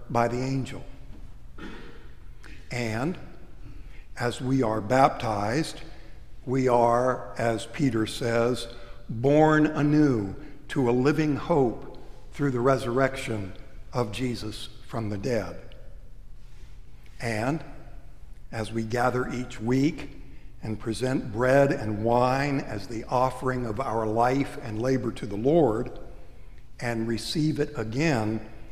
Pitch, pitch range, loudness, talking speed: 120 Hz, 110-135 Hz, -26 LUFS, 110 wpm